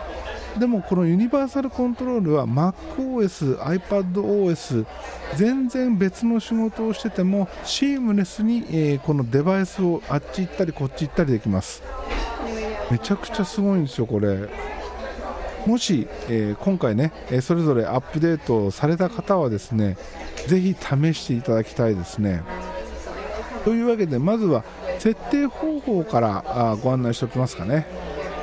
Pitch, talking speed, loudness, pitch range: 175 Hz, 310 characters per minute, -23 LUFS, 130-210 Hz